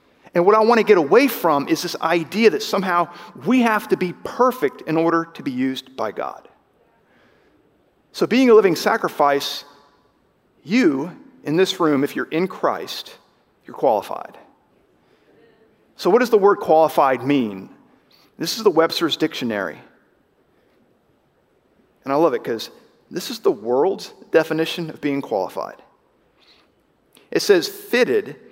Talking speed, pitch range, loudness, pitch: 145 wpm, 160-230 Hz, -19 LUFS, 175 Hz